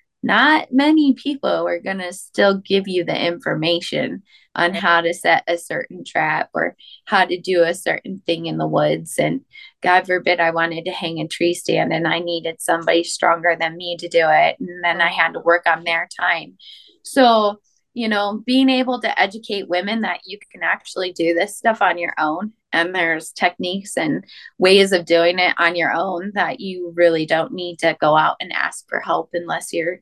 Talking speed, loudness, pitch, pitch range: 200 wpm, -18 LUFS, 175 Hz, 170-200 Hz